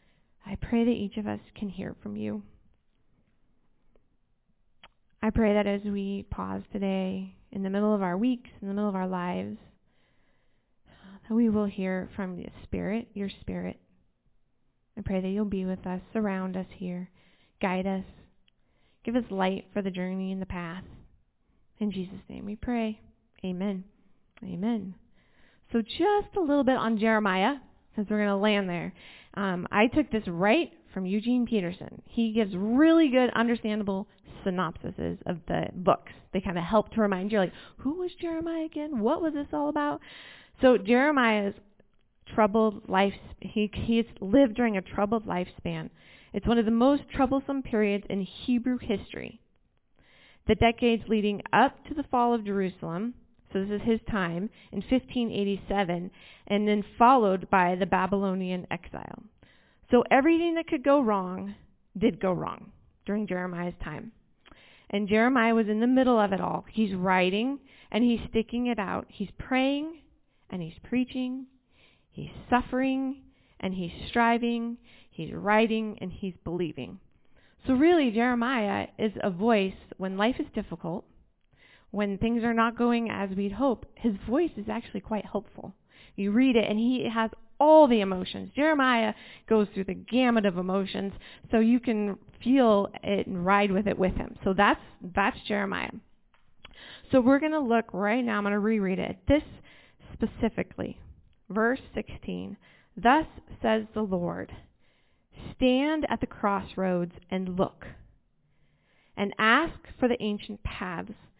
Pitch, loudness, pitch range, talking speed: 215 Hz, -27 LUFS, 195-240 Hz, 155 wpm